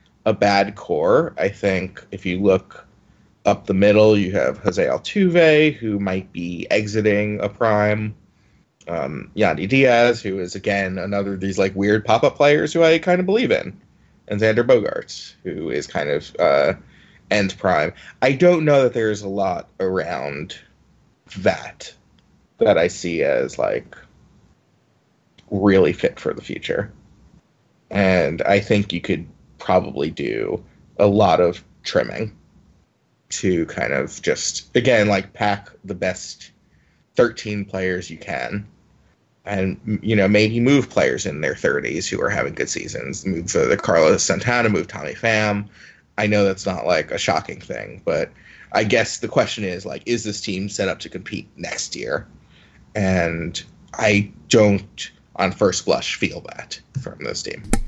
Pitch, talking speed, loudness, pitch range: 100 Hz, 155 wpm, -20 LUFS, 95-110 Hz